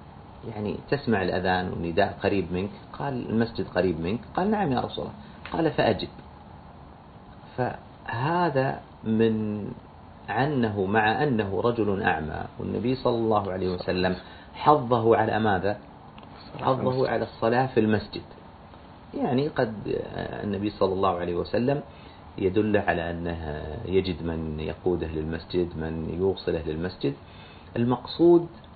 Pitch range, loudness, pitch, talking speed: 85-115 Hz, -26 LUFS, 100 Hz, 115 wpm